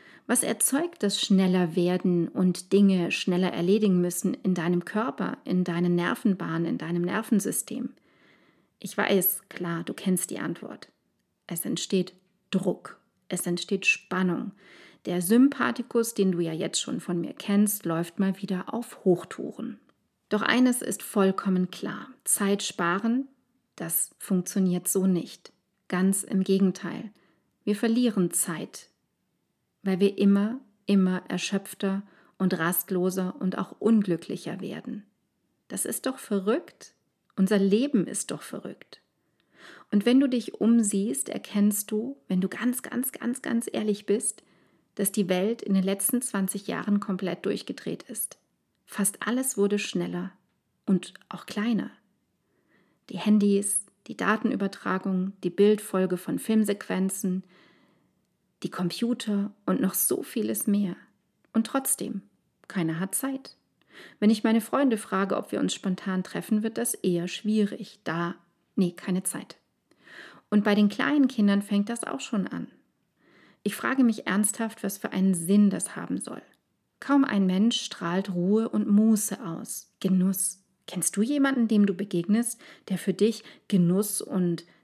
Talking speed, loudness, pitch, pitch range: 140 wpm, -27 LUFS, 200 Hz, 185-225 Hz